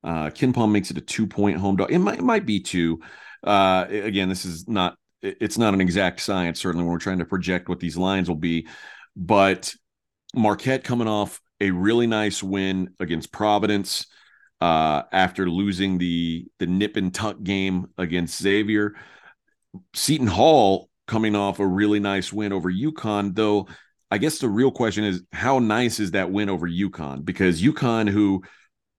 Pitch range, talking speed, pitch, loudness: 90-105 Hz, 175 wpm, 95 Hz, -22 LUFS